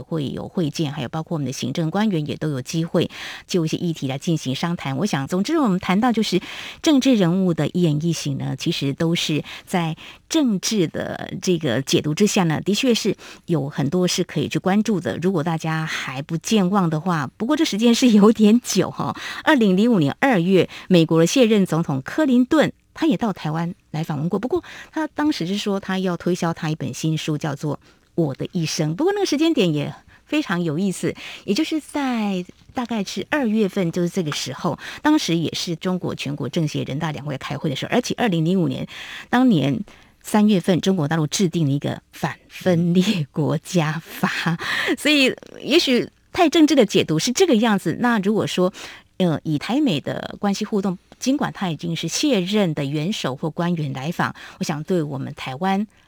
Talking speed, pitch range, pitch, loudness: 290 characters per minute, 160-215 Hz, 180 Hz, -21 LUFS